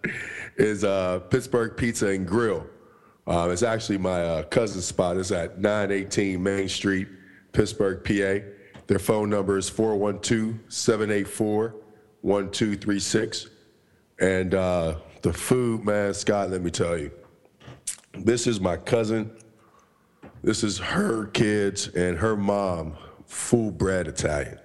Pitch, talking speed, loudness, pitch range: 100 Hz, 125 wpm, -25 LUFS, 95-110 Hz